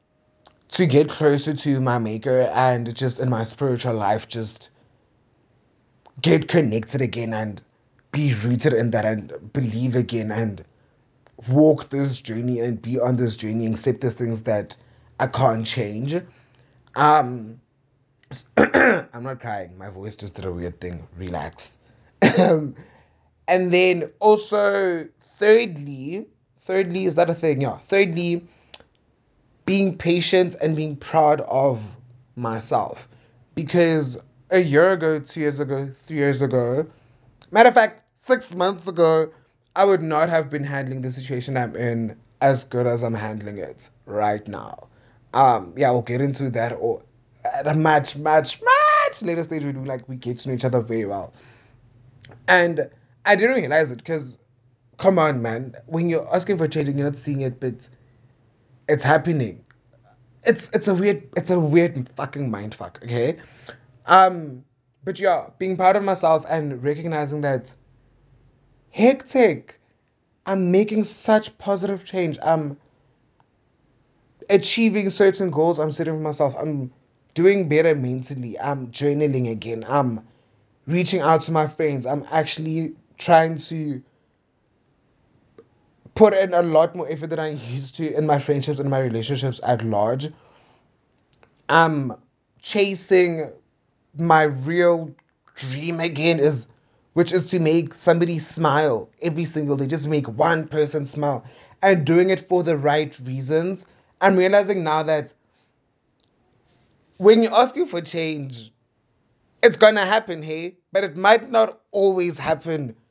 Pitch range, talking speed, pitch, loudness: 125-170 Hz, 145 wpm, 145 Hz, -21 LUFS